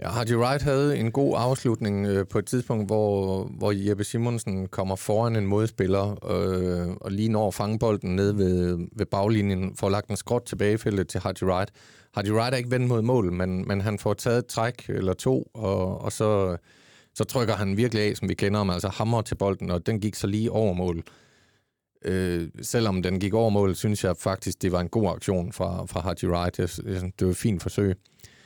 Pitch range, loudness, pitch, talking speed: 95-115 Hz, -26 LUFS, 100 Hz, 210 wpm